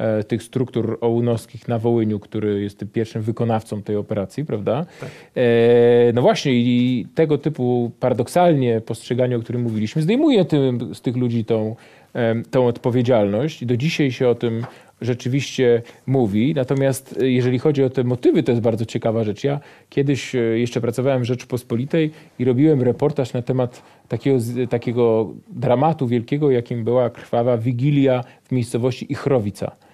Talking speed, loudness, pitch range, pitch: 145 wpm, -20 LUFS, 115-130 Hz, 125 Hz